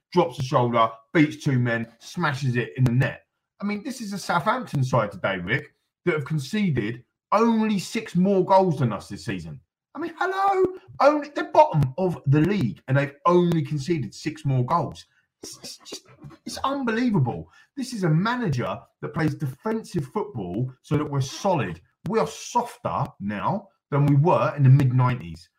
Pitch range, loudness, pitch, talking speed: 135-205 Hz, -24 LUFS, 160 Hz, 175 wpm